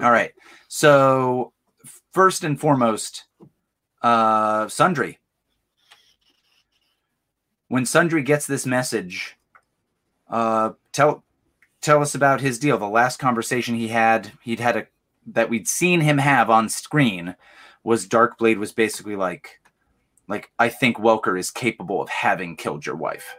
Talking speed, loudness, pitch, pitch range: 130 wpm, -20 LUFS, 120 Hz, 110-140 Hz